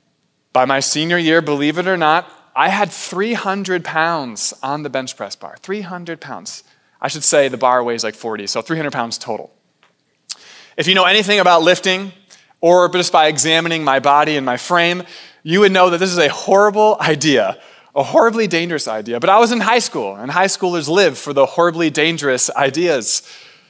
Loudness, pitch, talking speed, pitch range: -15 LUFS, 170 Hz, 185 wpm, 145-190 Hz